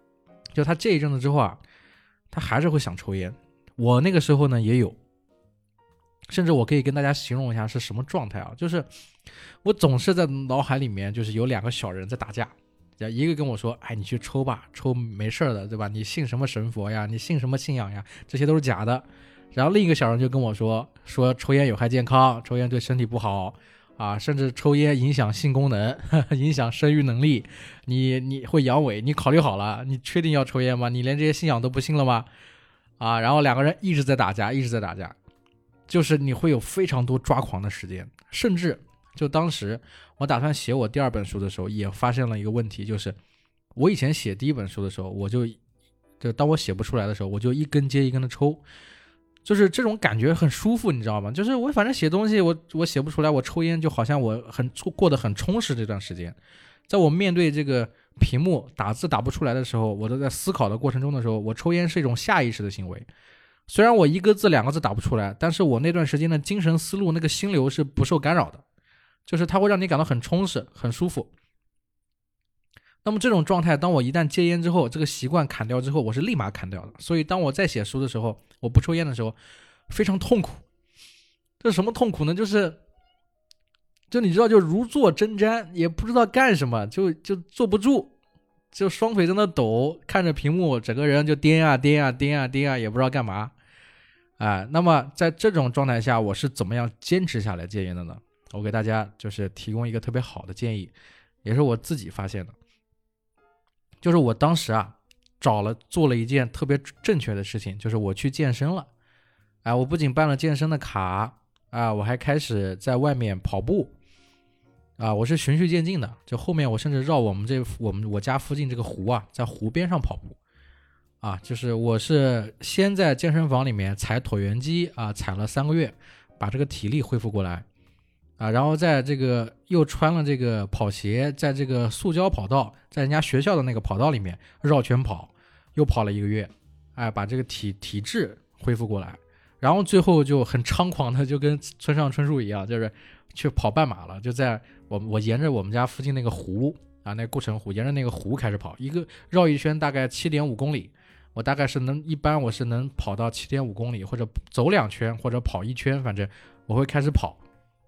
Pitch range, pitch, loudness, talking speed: 110-150 Hz, 130 Hz, -24 LUFS, 310 characters per minute